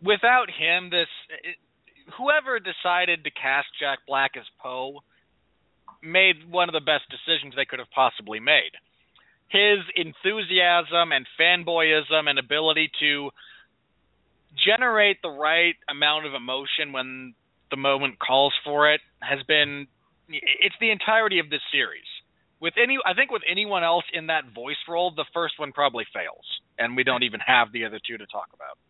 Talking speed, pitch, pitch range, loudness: 160 wpm, 155 Hz, 140-180 Hz, -22 LUFS